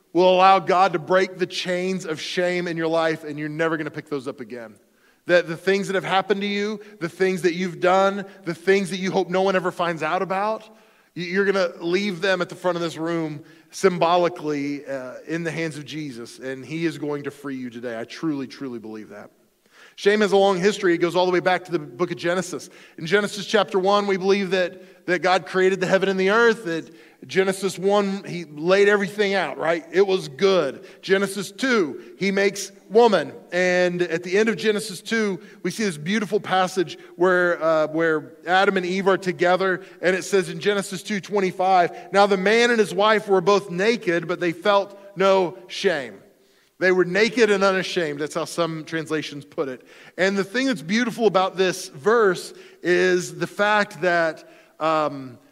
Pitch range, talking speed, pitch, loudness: 165-195 Hz, 205 wpm, 185 Hz, -22 LUFS